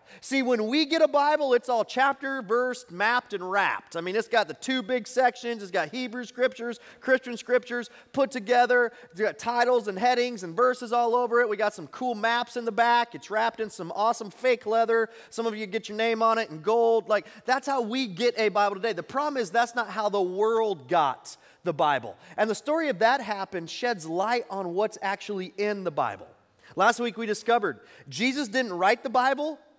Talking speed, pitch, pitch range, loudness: 215 wpm, 235 Hz, 210-250 Hz, -26 LUFS